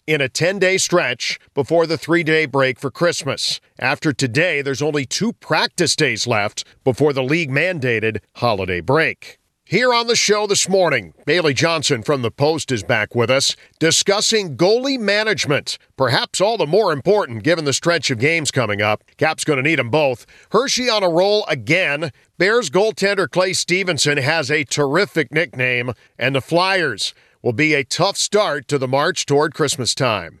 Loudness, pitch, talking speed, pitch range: -17 LUFS, 155 Hz, 175 wpm, 135-175 Hz